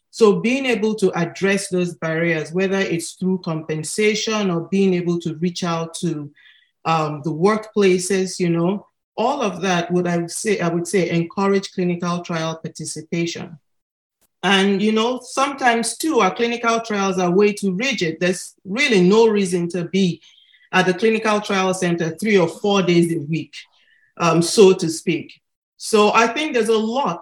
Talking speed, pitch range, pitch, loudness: 170 wpm, 170-210 Hz, 185 Hz, -19 LUFS